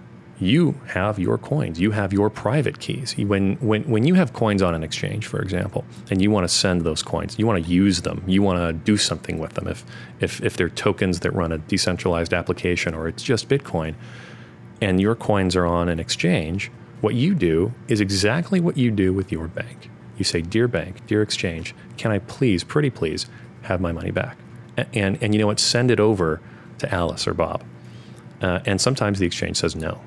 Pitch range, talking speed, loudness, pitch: 85-115 Hz, 210 wpm, -22 LUFS, 100 Hz